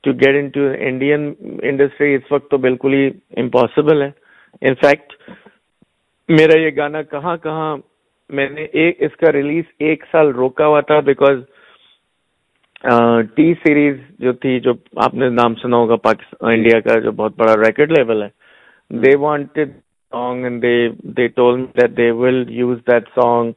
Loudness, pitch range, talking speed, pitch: -15 LUFS, 120-150 Hz, 120 wpm, 135 Hz